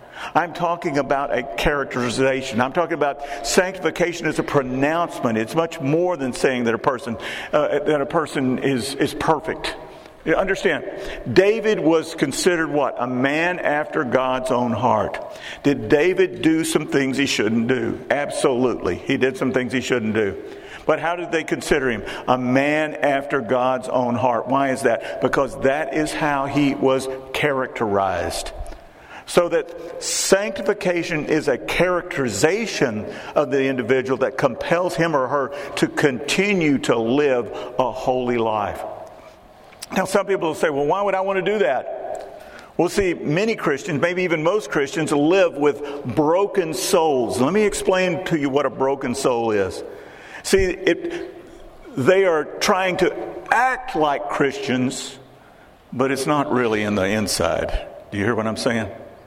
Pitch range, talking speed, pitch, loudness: 130-180 Hz, 165 wpm, 145 Hz, -21 LUFS